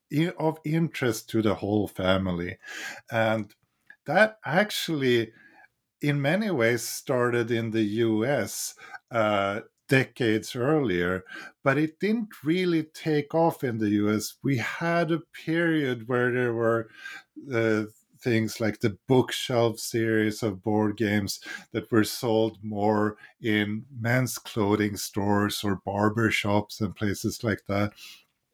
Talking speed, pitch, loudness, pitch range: 125 wpm, 115 Hz, -26 LUFS, 105-140 Hz